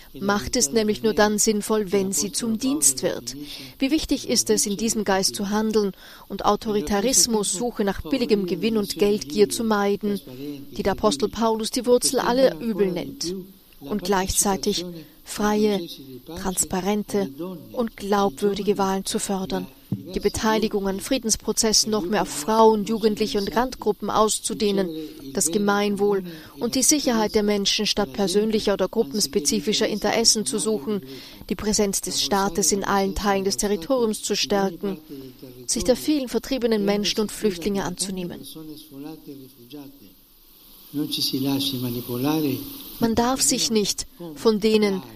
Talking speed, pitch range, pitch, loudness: 130 wpm, 185-220 Hz, 205 Hz, -22 LUFS